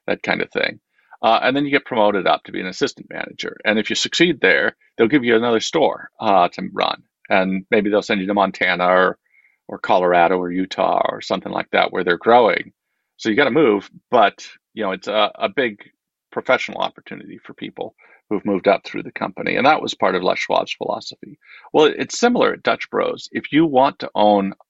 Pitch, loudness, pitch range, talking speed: 105 Hz, -18 LUFS, 95-145 Hz, 220 wpm